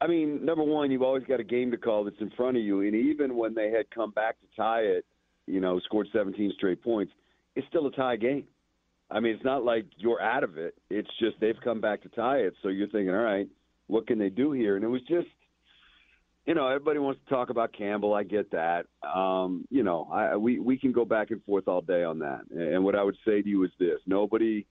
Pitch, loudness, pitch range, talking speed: 110 Hz, -29 LUFS, 100-125 Hz, 255 wpm